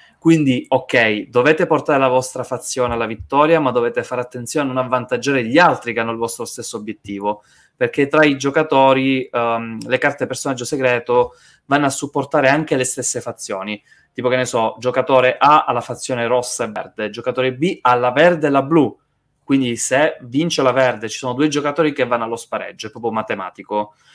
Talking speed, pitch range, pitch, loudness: 190 wpm, 120-140 Hz, 125 Hz, -17 LUFS